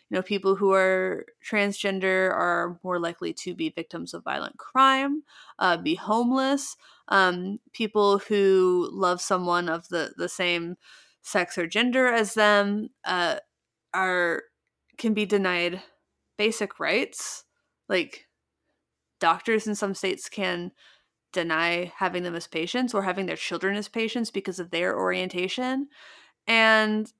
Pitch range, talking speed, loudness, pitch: 180-220 Hz, 135 wpm, -25 LUFS, 195 Hz